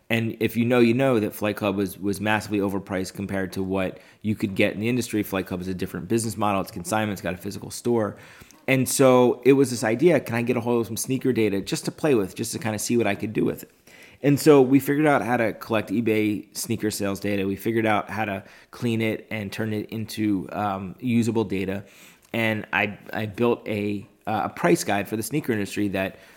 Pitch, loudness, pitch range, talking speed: 110 Hz, -24 LUFS, 100-115 Hz, 240 wpm